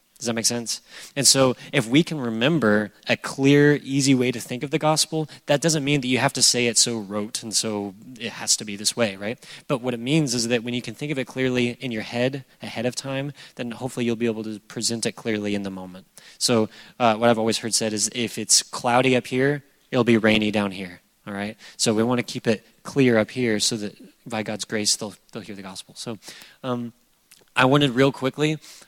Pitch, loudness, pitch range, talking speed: 120 Hz, -22 LUFS, 110-135 Hz, 240 wpm